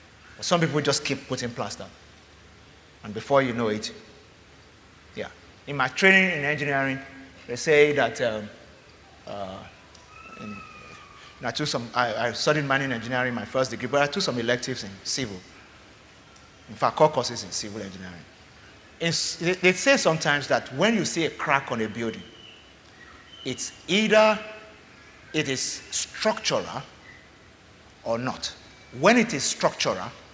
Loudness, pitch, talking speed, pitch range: -24 LUFS, 125 Hz, 145 wpm, 100-145 Hz